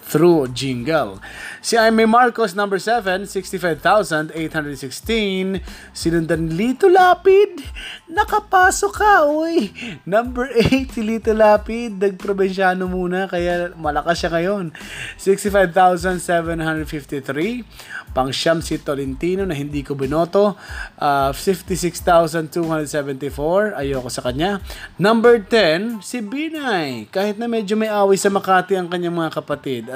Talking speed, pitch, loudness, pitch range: 110 wpm, 185 Hz, -18 LUFS, 160-225 Hz